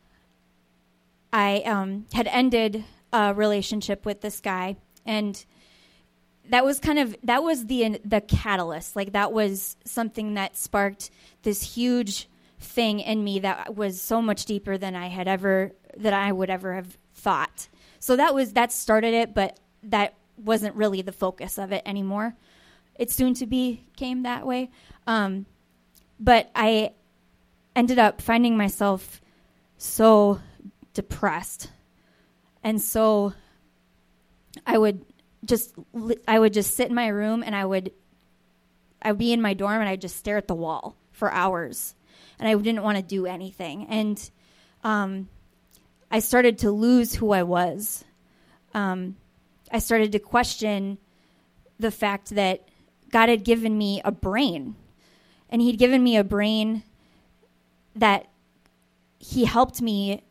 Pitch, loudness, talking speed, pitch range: 210 Hz, -24 LUFS, 145 wpm, 190-230 Hz